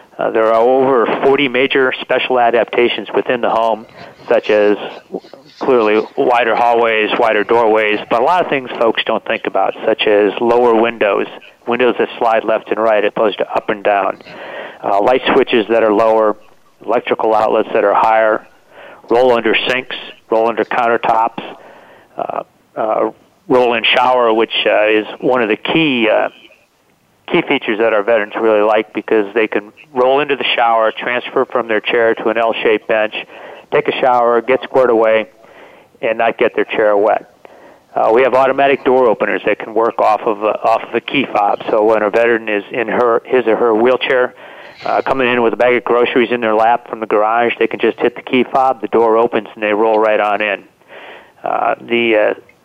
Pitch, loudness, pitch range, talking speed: 115 Hz, -14 LUFS, 110-125 Hz, 190 wpm